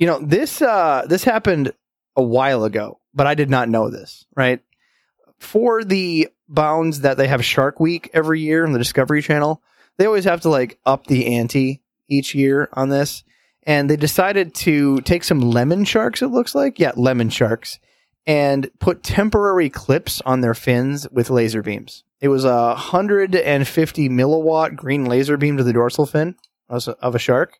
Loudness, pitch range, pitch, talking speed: -18 LUFS, 125-165 Hz, 140 Hz, 180 wpm